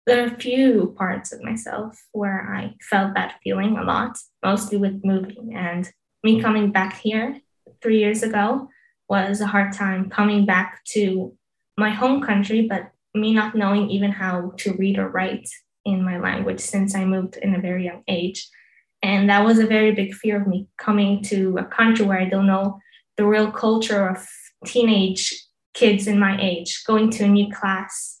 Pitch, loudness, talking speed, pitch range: 205 Hz, -21 LUFS, 185 wpm, 190-220 Hz